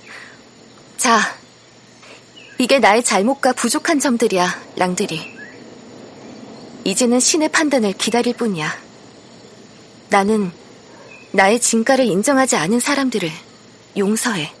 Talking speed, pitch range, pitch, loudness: 215 characters per minute, 205-255 Hz, 235 Hz, -16 LUFS